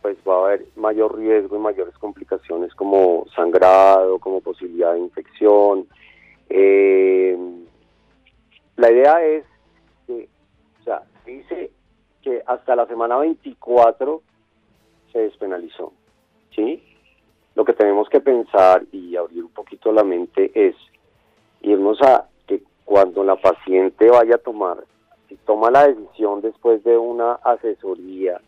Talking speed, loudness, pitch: 125 wpm, -17 LUFS, 110 Hz